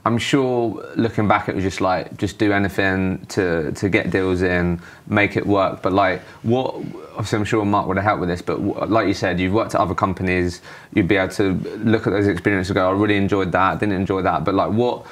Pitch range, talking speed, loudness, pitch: 95-110 Hz, 240 wpm, -20 LUFS, 100 Hz